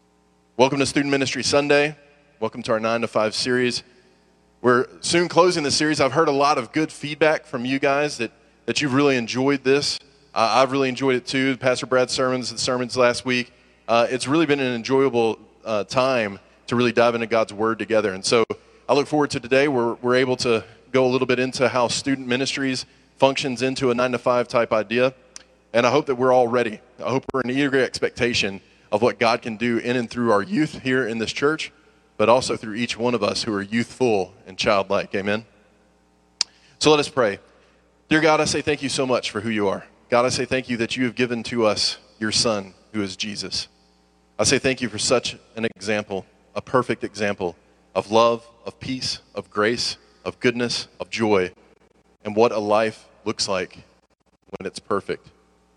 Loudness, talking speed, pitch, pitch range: -21 LUFS, 205 wpm, 125 Hz, 110-135 Hz